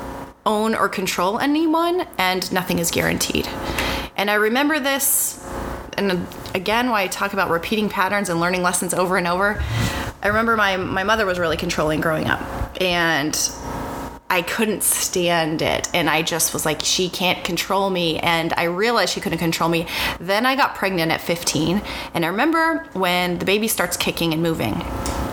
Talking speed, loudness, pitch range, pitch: 175 wpm, -20 LUFS, 165-205 Hz, 180 Hz